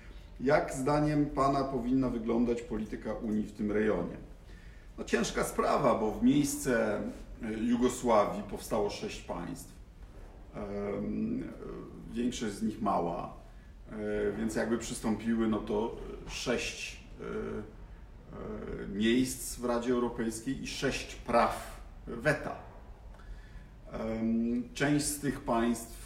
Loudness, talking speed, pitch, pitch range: -32 LUFS, 95 wpm, 115 Hz, 110-125 Hz